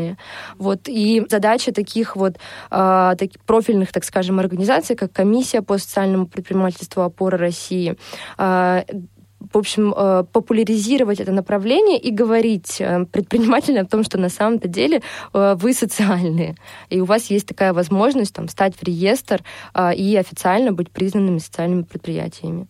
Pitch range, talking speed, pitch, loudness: 185-220 Hz, 130 wpm, 195 Hz, -18 LUFS